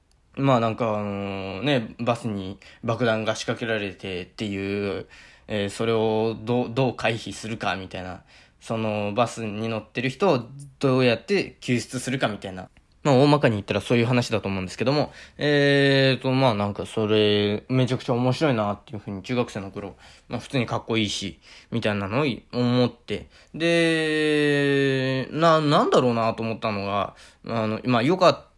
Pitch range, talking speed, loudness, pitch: 100-130 Hz, 350 characters per minute, -24 LUFS, 115 Hz